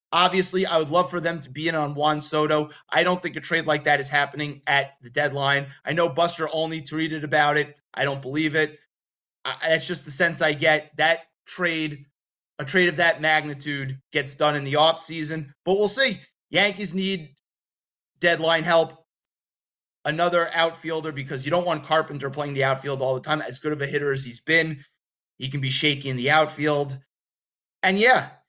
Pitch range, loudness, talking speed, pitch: 140-165 Hz, -23 LUFS, 190 wpm, 155 Hz